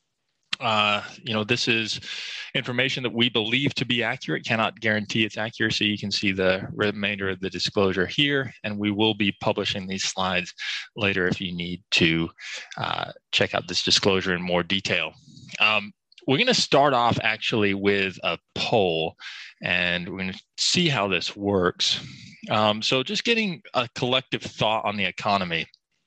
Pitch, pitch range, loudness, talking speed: 105 Hz, 95-120 Hz, -23 LUFS, 170 wpm